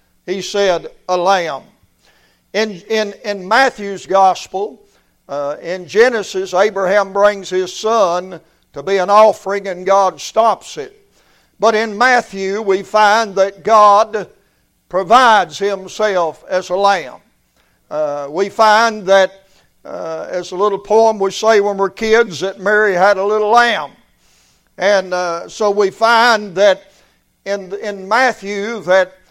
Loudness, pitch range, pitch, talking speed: -14 LUFS, 185-215 Hz, 200 Hz, 135 wpm